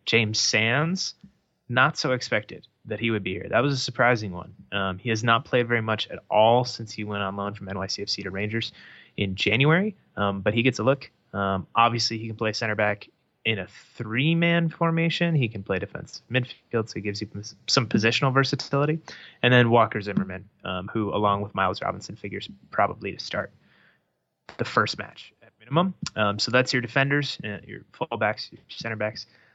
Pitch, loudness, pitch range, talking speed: 115 Hz, -25 LUFS, 100-130 Hz, 190 wpm